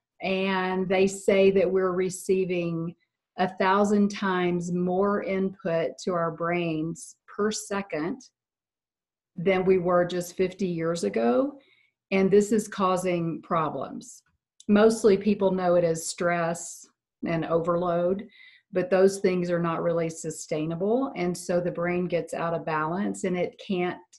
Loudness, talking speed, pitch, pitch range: -26 LUFS, 135 wpm, 180 Hz, 170-195 Hz